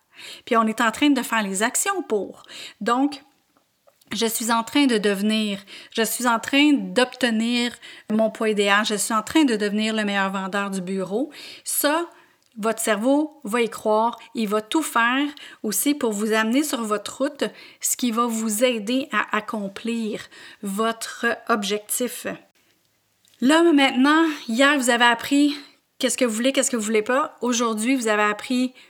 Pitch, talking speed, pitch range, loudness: 235 Hz, 170 wpm, 220-280 Hz, -22 LUFS